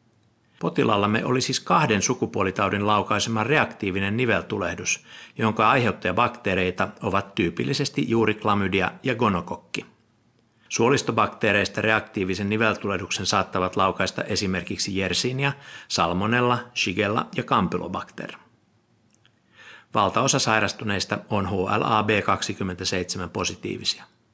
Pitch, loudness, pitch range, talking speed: 105 Hz, -23 LUFS, 95-115 Hz, 75 wpm